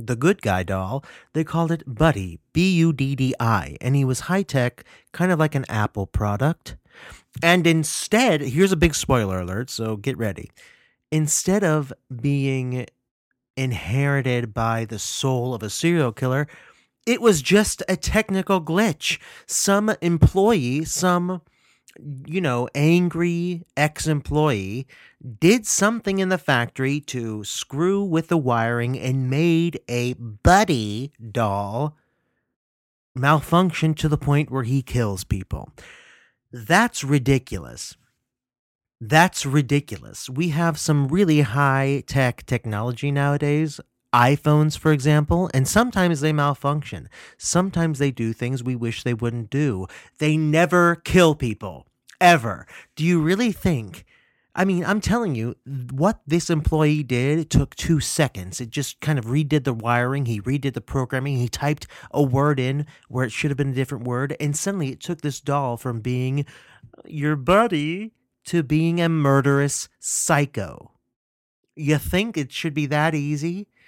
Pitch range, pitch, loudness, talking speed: 125-165 Hz, 145 Hz, -21 LUFS, 145 wpm